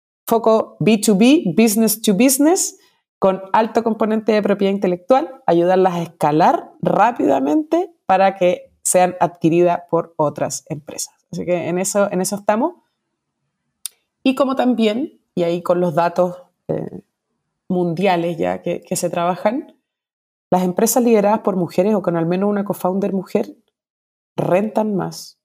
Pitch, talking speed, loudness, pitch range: 195 Hz, 135 wpm, -18 LUFS, 175-225 Hz